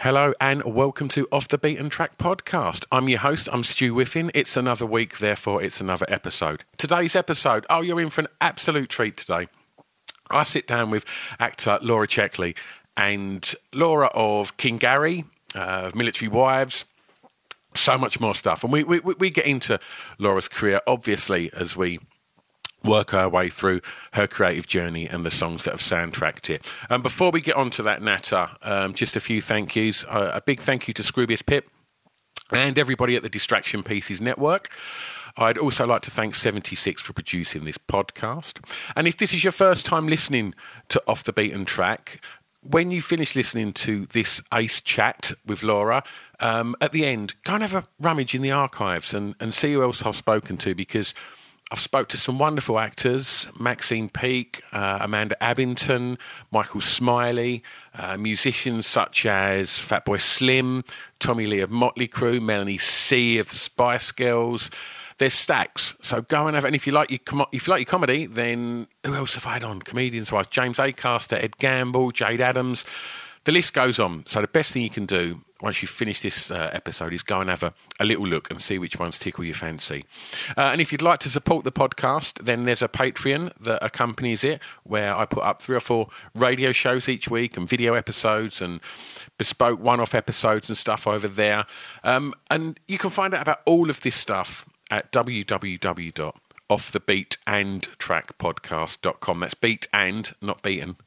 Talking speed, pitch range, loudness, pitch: 185 wpm, 105-135 Hz, -23 LUFS, 120 Hz